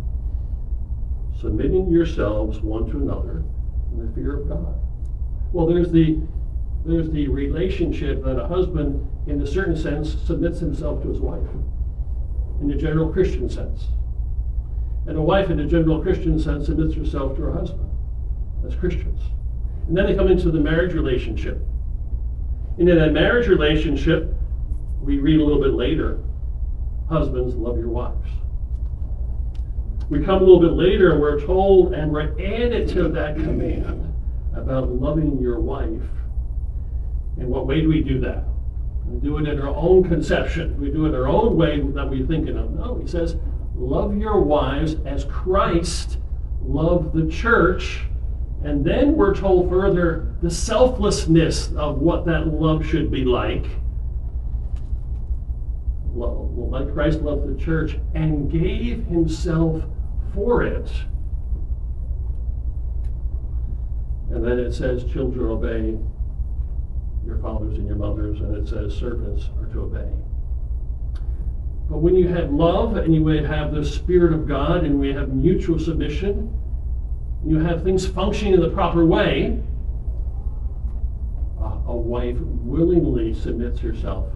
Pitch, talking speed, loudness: 75 Hz, 145 wpm, -22 LUFS